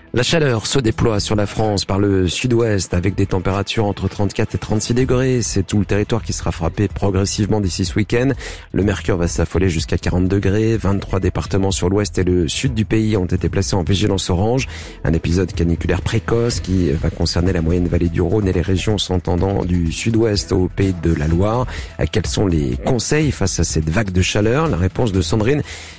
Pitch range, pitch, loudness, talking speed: 90-110 Hz, 95 Hz, -18 LUFS, 205 wpm